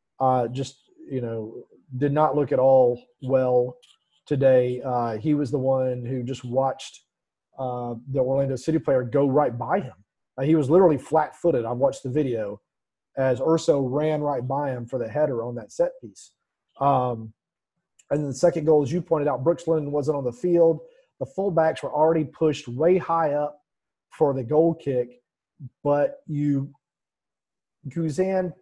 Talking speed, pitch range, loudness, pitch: 170 wpm, 130-160 Hz, -24 LUFS, 145 Hz